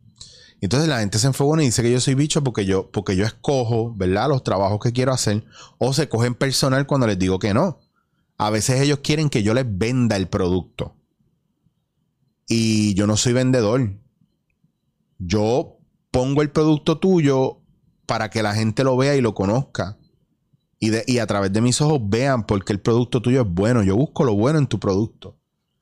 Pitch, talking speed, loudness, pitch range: 120 Hz, 195 wpm, -20 LUFS, 105-135 Hz